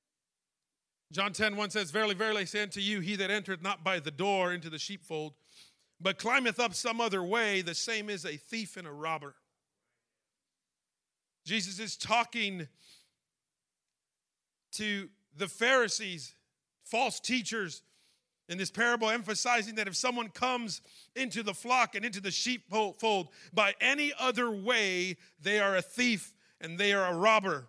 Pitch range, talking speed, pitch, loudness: 175-225 Hz, 150 wpm, 200 Hz, -31 LUFS